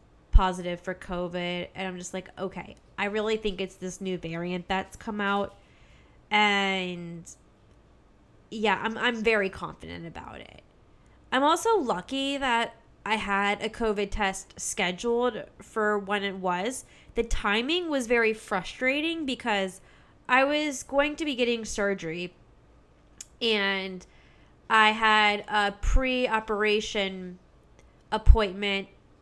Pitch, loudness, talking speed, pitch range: 205 Hz, -27 LUFS, 125 wpm, 185-225 Hz